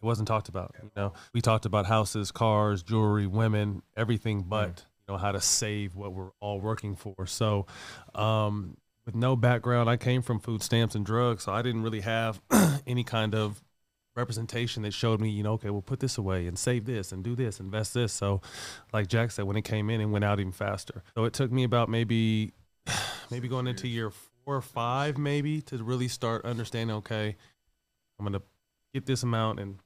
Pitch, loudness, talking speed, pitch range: 110 Hz, -30 LUFS, 205 wpm, 100-120 Hz